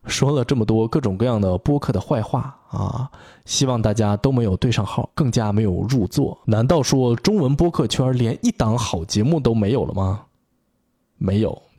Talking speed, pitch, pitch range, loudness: 270 characters per minute, 120 Hz, 105-135 Hz, -20 LUFS